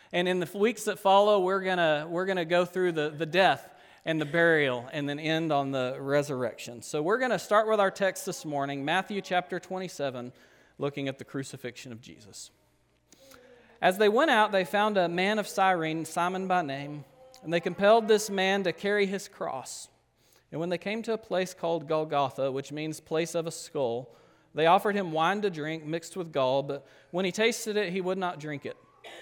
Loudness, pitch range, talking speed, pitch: -28 LUFS, 145-195 Hz, 205 wpm, 175 Hz